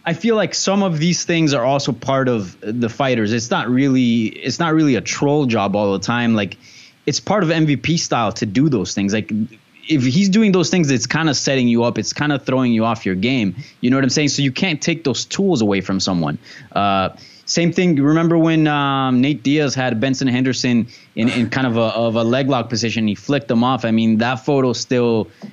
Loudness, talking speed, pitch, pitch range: -17 LUFS, 235 wpm, 130 Hz, 115-150 Hz